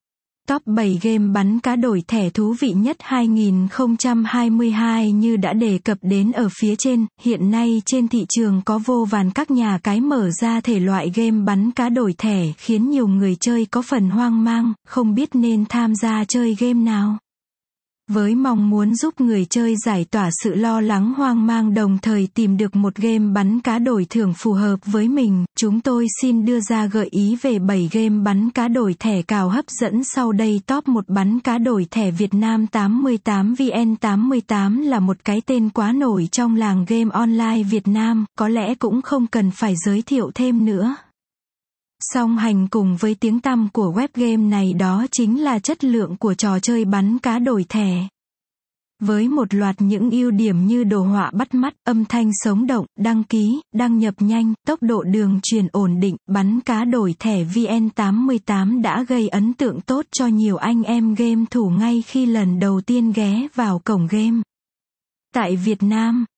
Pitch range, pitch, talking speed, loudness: 205-240 Hz, 225 Hz, 190 wpm, -18 LUFS